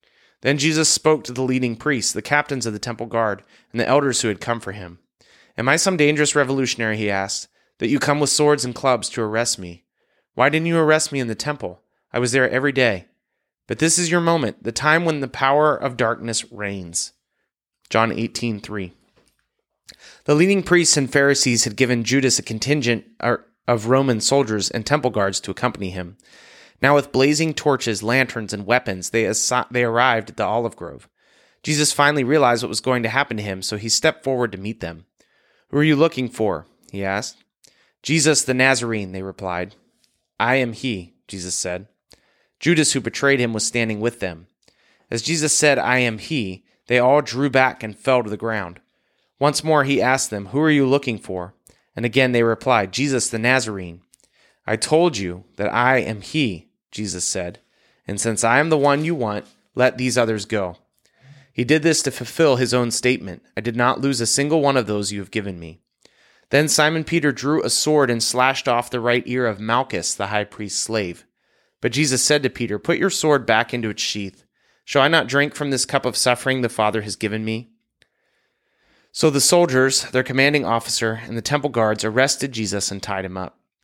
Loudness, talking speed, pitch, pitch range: -19 LUFS, 200 wpm, 125 Hz, 110-140 Hz